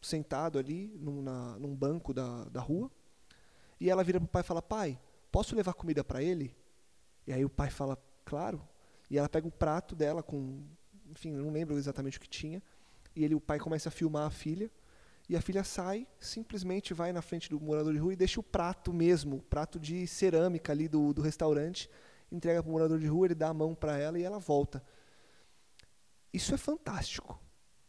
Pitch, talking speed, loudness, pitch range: 160 Hz, 205 wpm, -35 LUFS, 145-180 Hz